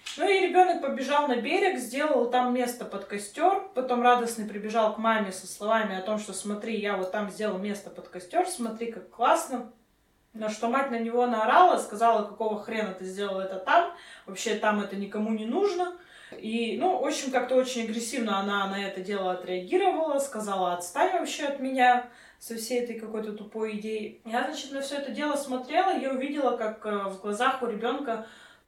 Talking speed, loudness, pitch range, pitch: 185 wpm, -28 LUFS, 210-270 Hz, 230 Hz